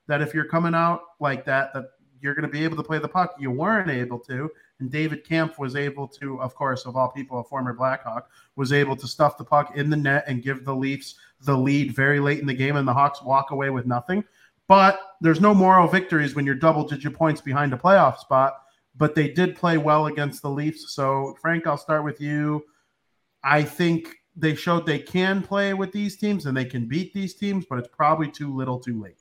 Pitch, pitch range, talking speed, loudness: 145 Hz, 135-165 Hz, 230 wpm, -23 LUFS